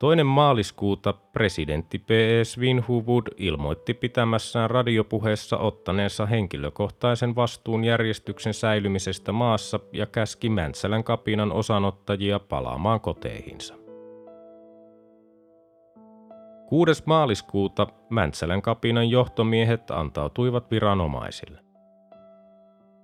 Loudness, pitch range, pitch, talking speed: -24 LUFS, 100-130 Hz, 115 Hz, 75 wpm